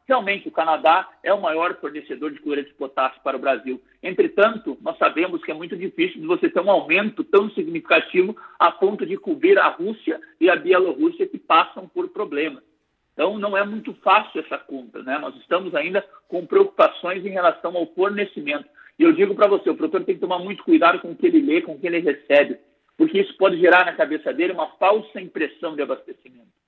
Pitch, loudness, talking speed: 290 Hz, -20 LUFS, 205 wpm